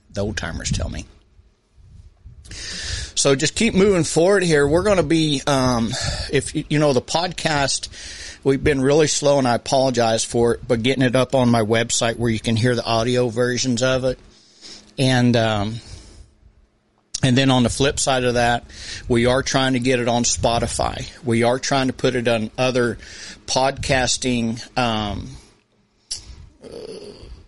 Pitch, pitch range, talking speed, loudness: 125 Hz, 115-135 Hz, 165 wpm, -19 LUFS